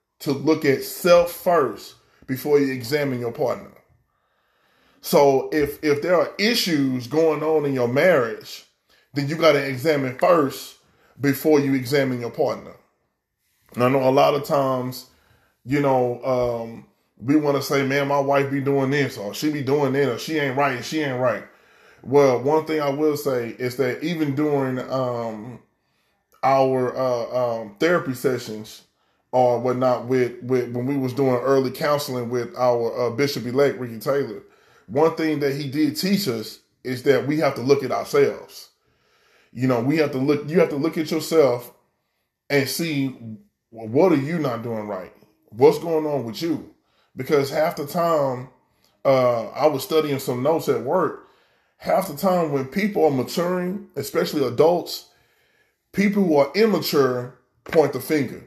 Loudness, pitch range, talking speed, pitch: -21 LUFS, 125-155 Hz, 170 wpm, 140 Hz